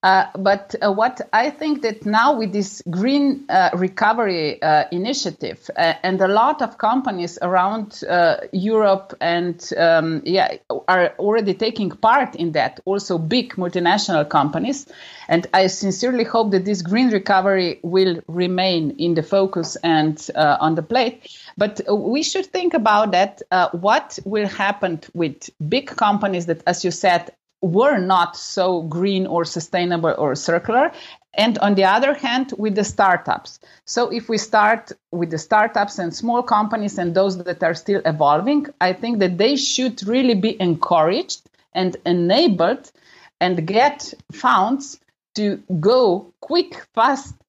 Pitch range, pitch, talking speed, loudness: 175-225 Hz, 195 Hz, 155 wpm, -19 LUFS